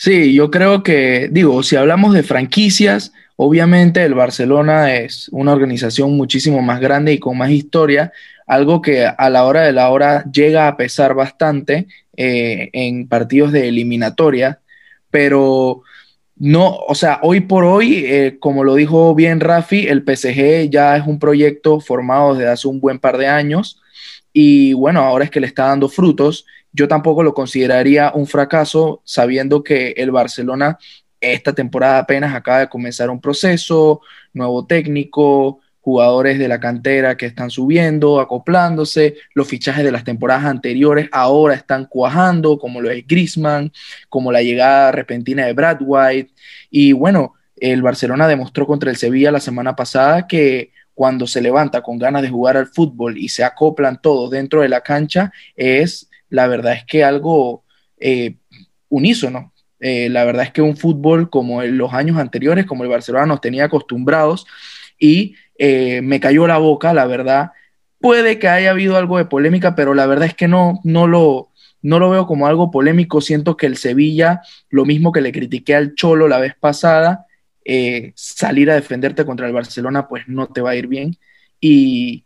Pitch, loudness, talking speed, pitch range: 145 Hz, -13 LUFS, 170 wpm, 130-160 Hz